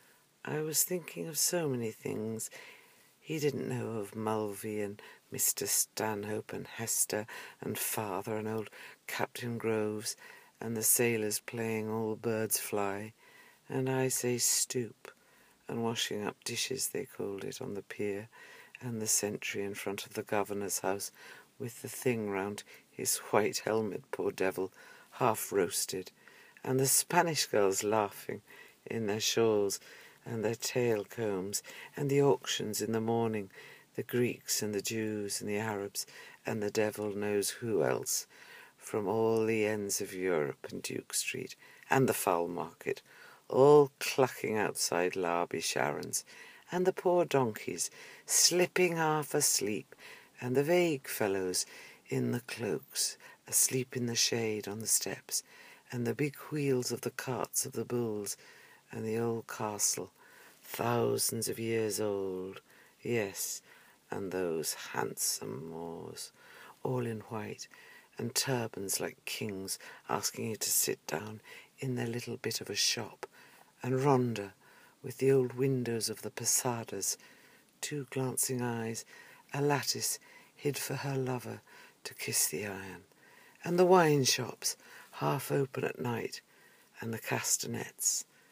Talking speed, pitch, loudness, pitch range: 140 wpm, 115 Hz, -33 LUFS, 105-130 Hz